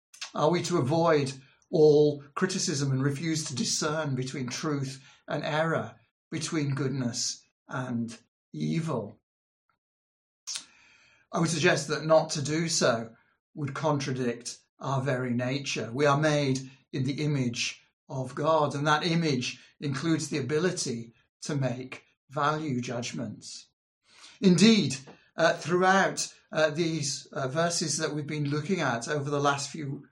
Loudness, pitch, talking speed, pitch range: -28 LUFS, 145 Hz, 130 wpm, 130-160 Hz